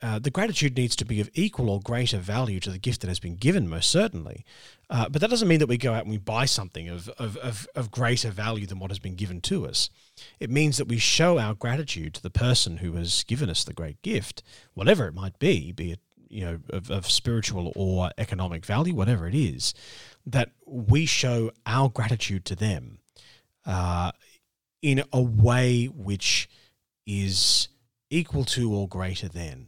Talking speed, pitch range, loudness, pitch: 200 wpm, 95-125 Hz, -26 LUFS, 115 Hz